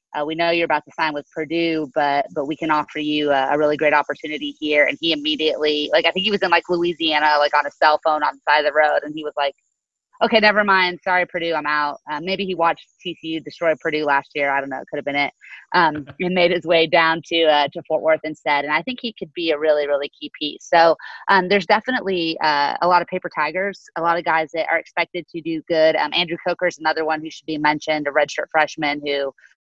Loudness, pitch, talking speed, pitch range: -19 LUFS, 155 Hz, 255 wpm, 150-175 Hz